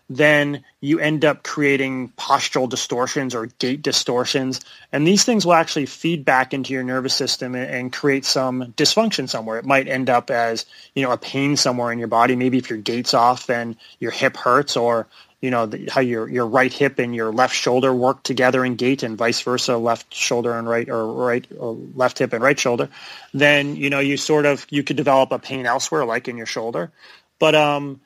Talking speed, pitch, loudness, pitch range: 210 wpm, 130 Hz, -19 LUFS, 120-140 Hz